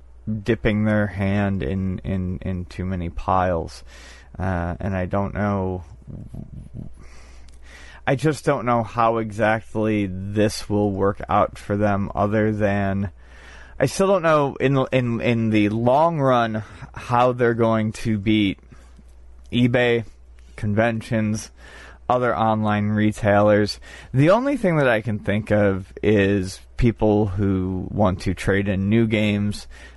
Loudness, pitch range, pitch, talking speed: -21 LUFS, 95-115 Hz, 105 Hz, 130 wpm